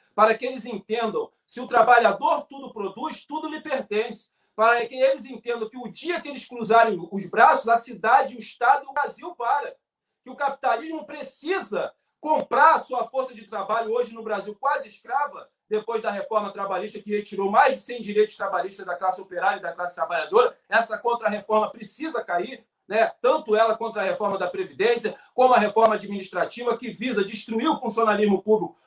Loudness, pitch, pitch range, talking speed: -24 LUFS, 230 Hz, 210-275 Hz, 180 wpm